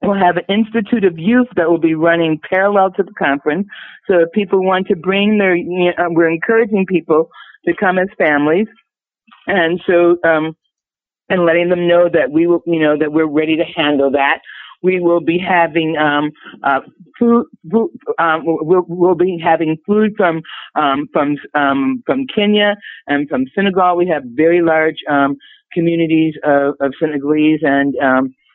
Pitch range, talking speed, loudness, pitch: 155-195 Hz, 170 wpm, -14 LUFS, 170 Hz